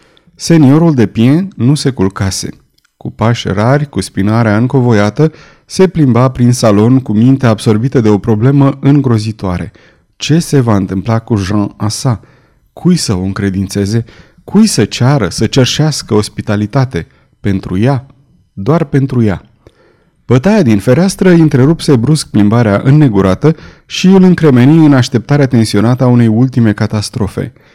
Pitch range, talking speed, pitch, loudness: 105-145 Hz, 135 wpm, 120 Hz, -10 LUFS